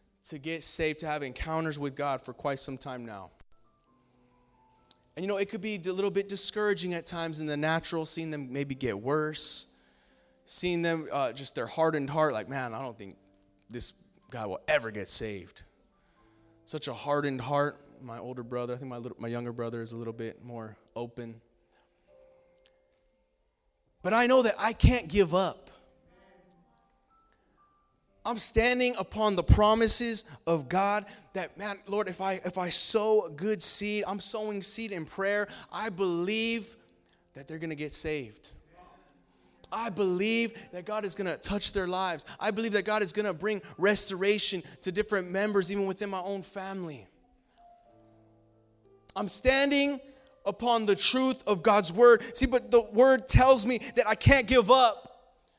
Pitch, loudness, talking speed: 170 Hz, -26 LUFS, 170 wpm